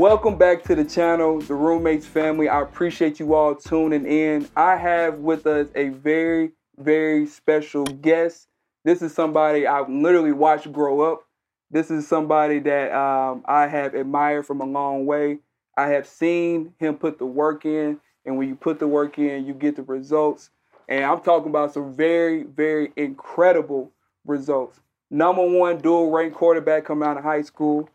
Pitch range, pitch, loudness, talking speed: 145-160 Hz, 155 Hz, -21 LUFS, 175 wpm